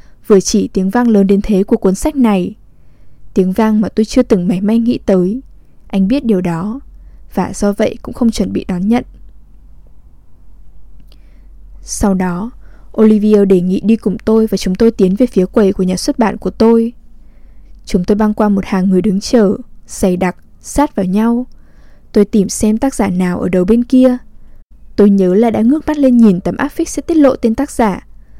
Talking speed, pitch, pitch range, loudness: 205 wpm, 215 Hz, 195-235 Hz, -13 LUFS